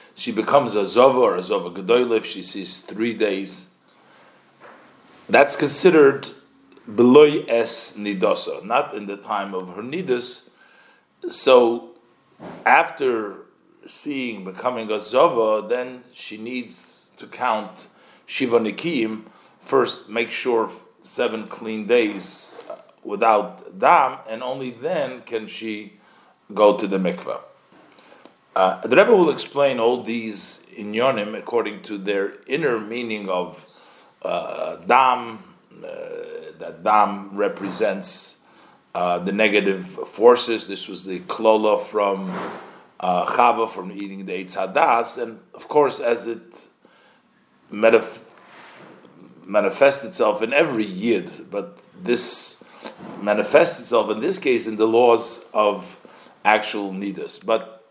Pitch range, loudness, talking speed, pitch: 100-125 Hz, -20 LUFS, 120 wpm, 110 Hz